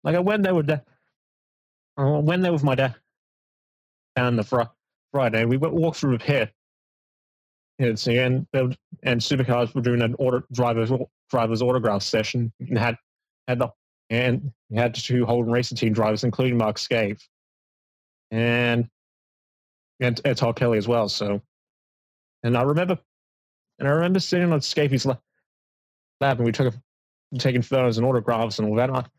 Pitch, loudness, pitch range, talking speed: 125 Hz, -23 LUFS, 115-135 Hz, 160 wpm